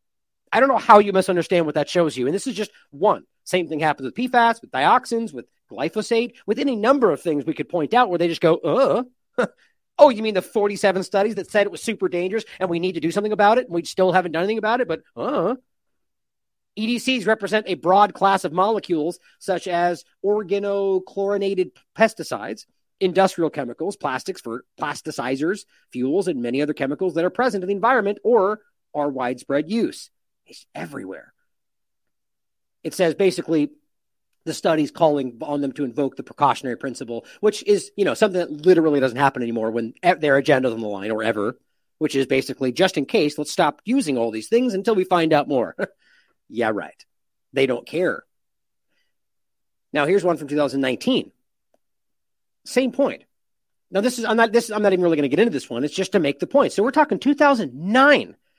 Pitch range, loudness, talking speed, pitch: 150-220 Hz, -21 LUFS, 190 wpm, 185 Hz